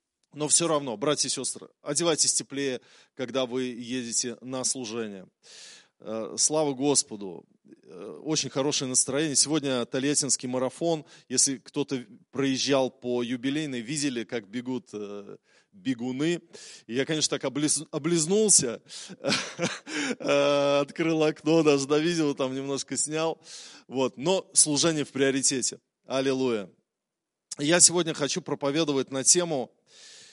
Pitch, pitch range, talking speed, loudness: 140 Hz, 130-155 Hz, 110 wpm, -26 LUFS